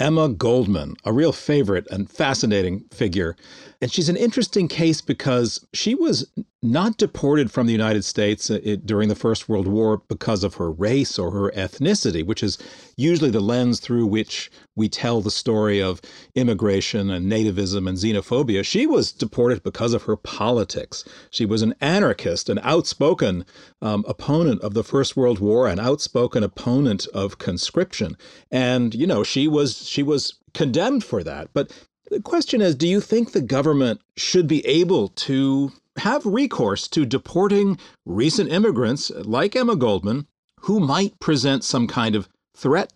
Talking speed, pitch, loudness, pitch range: 160 wpm, 120 Hz, -21 LUFS, 105-155 Hz